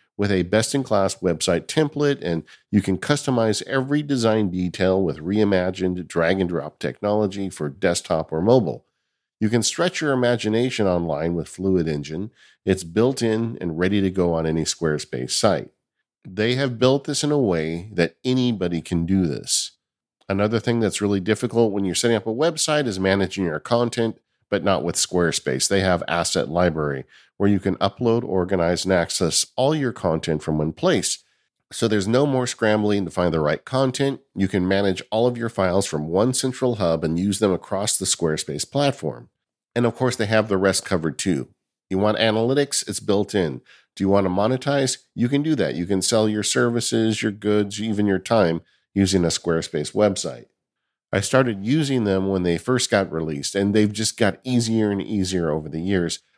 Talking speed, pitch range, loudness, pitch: 190 wpm, 90-115 Hz, -22 LUFS, 100 Hz